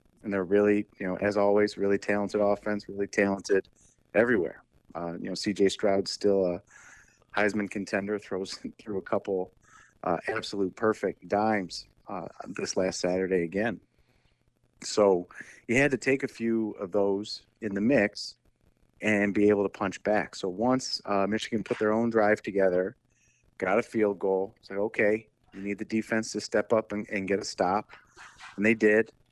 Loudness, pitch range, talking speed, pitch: -28 LUFS, 100-110 Hz, 170 wpm, 105 Hz